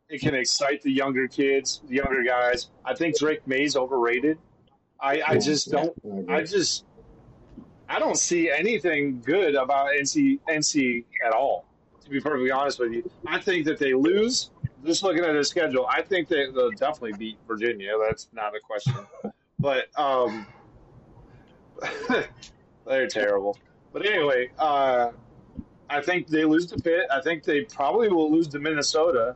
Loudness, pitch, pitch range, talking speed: -24 LUFS, 140 Hz, 125-160 Hz, 160 wpm